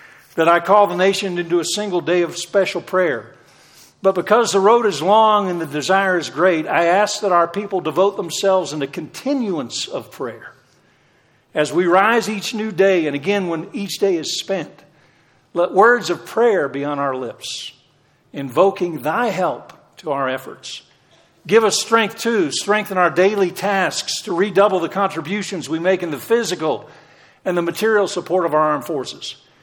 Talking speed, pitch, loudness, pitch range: 180 wpm, 185 Hz, -18 LUFS, 165-205 Hz